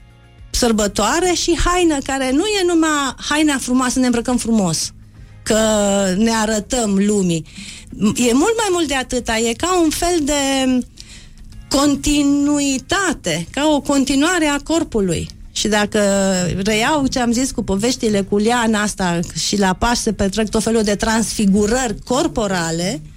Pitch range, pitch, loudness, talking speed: 205-285 Hz, 235 Hz, -17 LUFS, 140 wpm